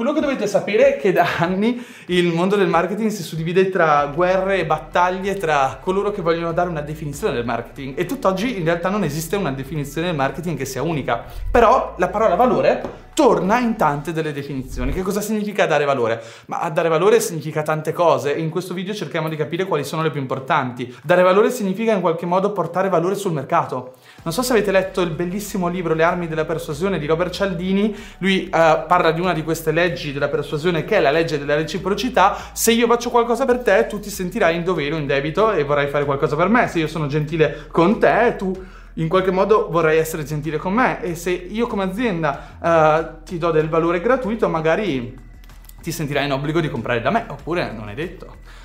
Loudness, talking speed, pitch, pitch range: -19 LUFS, 210 wpm, 170 Hz, 155-195 Hz